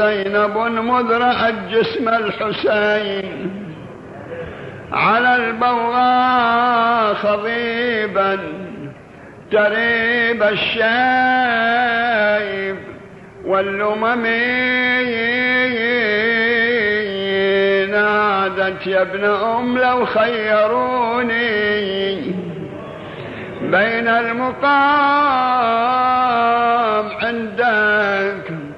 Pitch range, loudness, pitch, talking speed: 205-240 Hz, -16 LUFS, 225 Hz, 40 wpm